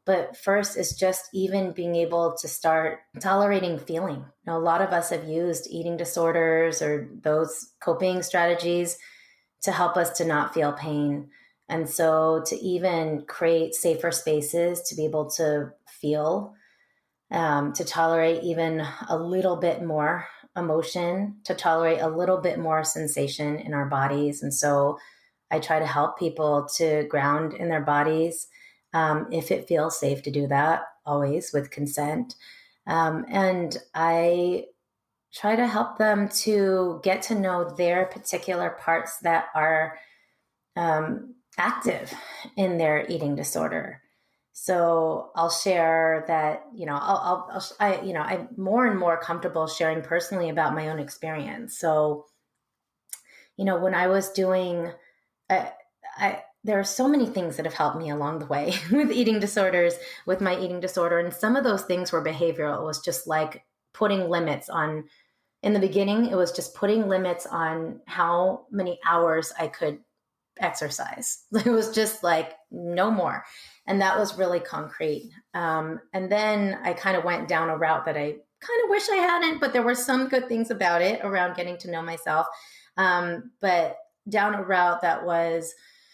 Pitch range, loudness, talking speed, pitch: 160-190 Hz, -25 LUFS, 165 wpm, 170 Hz